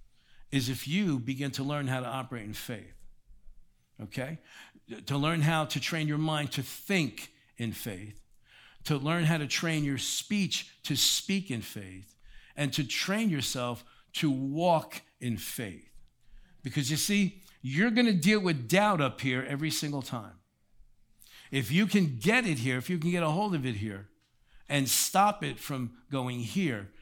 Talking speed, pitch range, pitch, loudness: 170 wpm, 120-165 Hz, 140 Hz, -30 LUFS